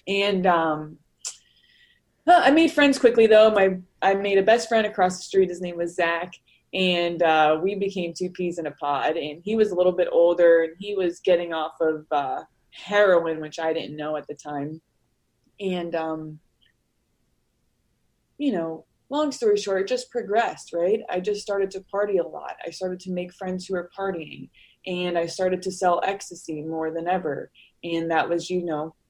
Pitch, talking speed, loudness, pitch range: 180 Hz, 190 wpm, -23 LUFS, 160-195 Hz